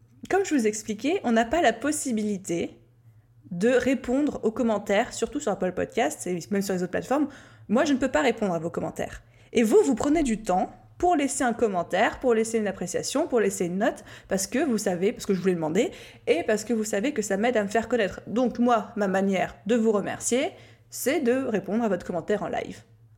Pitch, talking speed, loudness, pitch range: 220 Hz, 225 wpm, -26 LUFS, 190-250 Hz